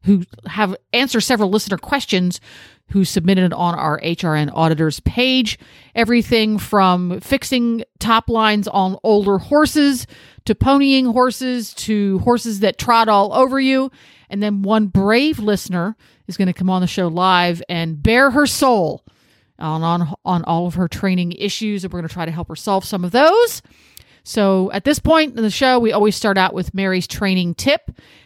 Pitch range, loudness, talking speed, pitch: 180-235 Hz, -17 LUFS, 175 wpm, 200 Hz